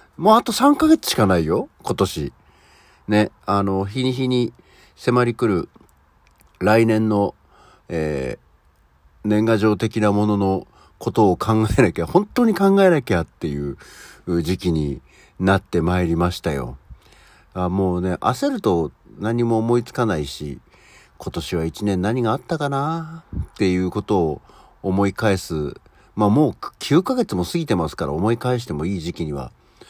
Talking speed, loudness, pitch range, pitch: 270 characters per minute, -20 LUFS, 85-125 Hz, 100 Hz